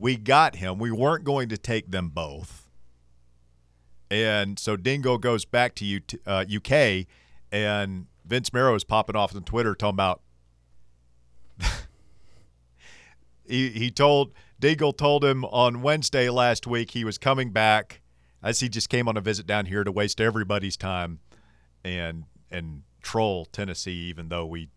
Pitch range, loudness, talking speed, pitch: 80-120 Hz, -25 LUFS, 150 wpm, 105 Hz